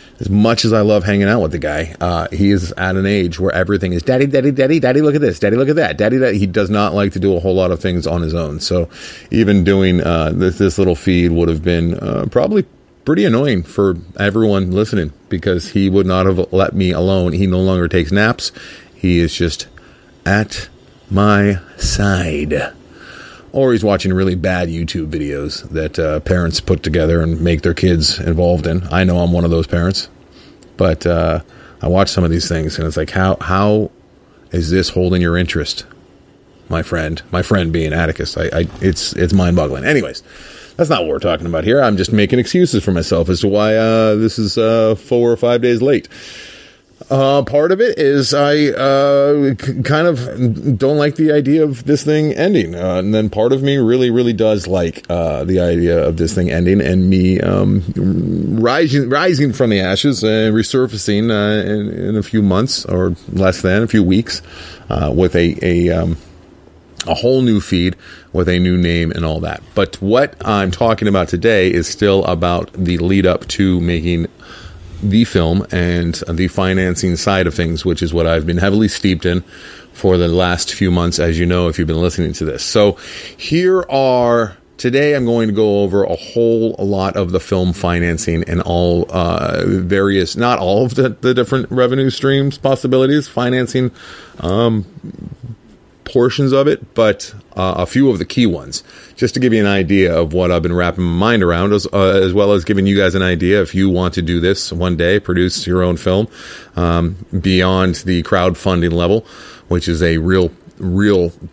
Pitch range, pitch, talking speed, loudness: 85-110 Hz, 95 Hz, 200 wpm, -15 LUFS